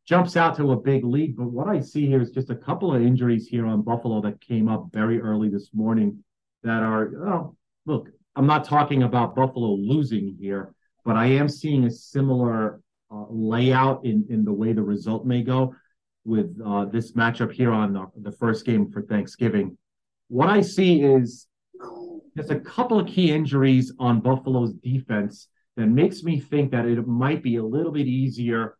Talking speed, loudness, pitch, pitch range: 190 wpm, -23 LUFS, 120 Hz, 110-135 Hz